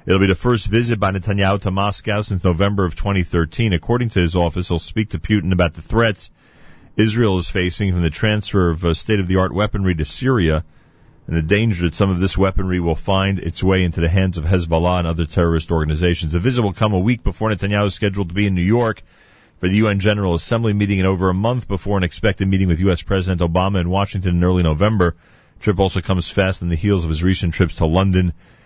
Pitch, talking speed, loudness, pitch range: 95 Hz, 225 wpm, -18 LUFS, 90-105 Hz